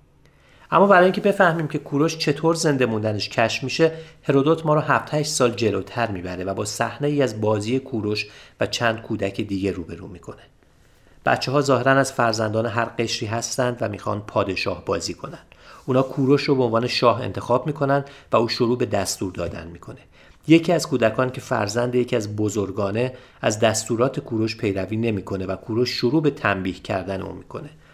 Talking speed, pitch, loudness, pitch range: 170 wpm, 115 Hz, -22 LUFS, 105-135 Hz